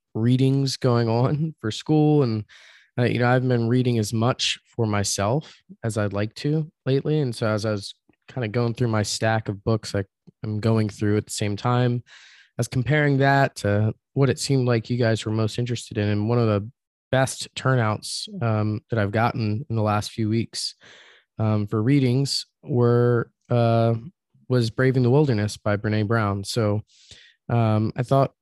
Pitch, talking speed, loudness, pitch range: 115 Hz, 185 wpm, -23 LUFS, 110-130 Hz